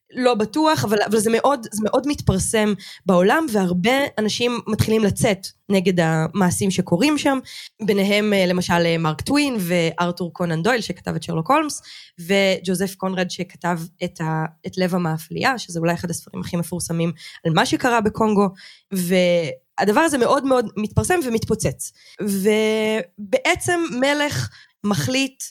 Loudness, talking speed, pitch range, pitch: -20 LUFS, 130 wpm, 175-240 Hz, 200 Hz